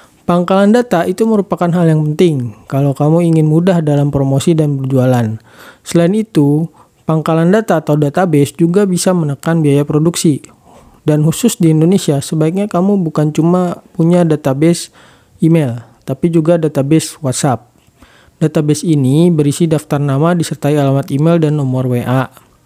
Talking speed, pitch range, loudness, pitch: 140 wpm, 145-175 Hz, -12 LUFS, 160 Hz